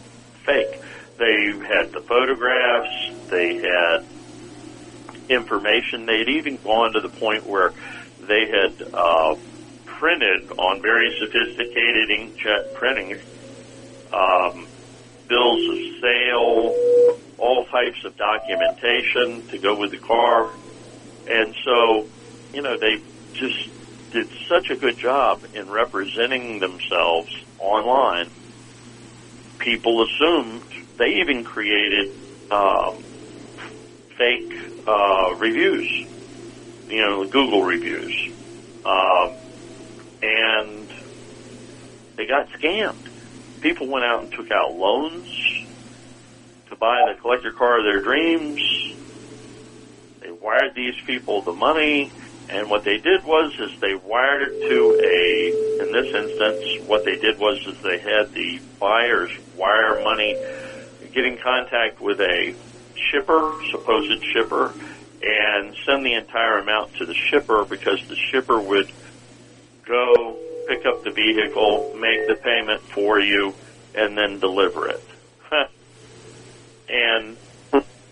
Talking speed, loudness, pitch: 115 wpm, -20 LUFS, 125 Hz